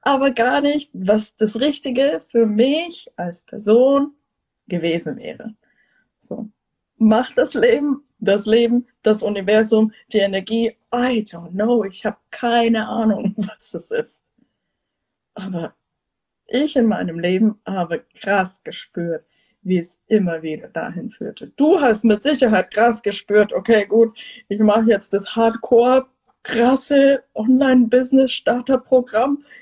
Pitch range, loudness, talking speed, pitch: 210-255 Hz, -18 LUFS, 125 wpm, 225 Hz